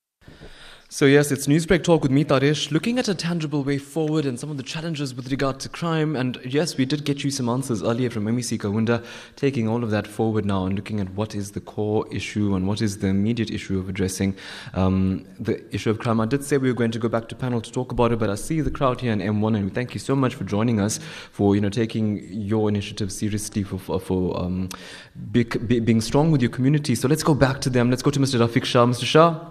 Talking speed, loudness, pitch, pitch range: 250 wpm, -23 LUFS, 120 Hz, 105-140 Hz